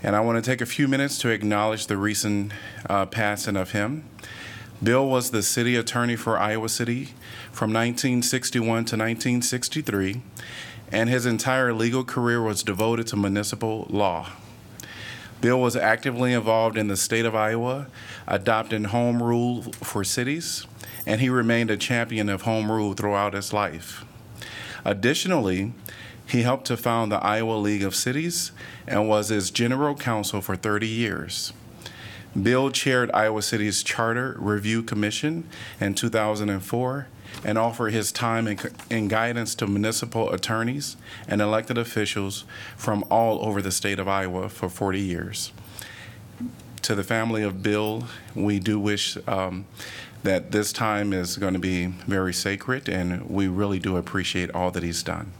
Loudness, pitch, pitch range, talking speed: -25 LUFS, 110 Hz, 100-120 Hz, 150 wpm